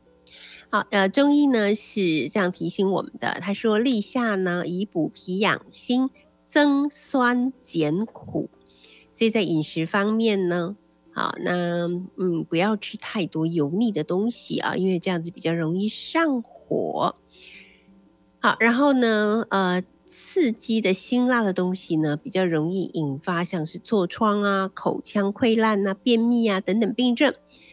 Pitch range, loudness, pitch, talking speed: 175-230 Hz, -23 LUFS, 195 Hz, 210 characters per minute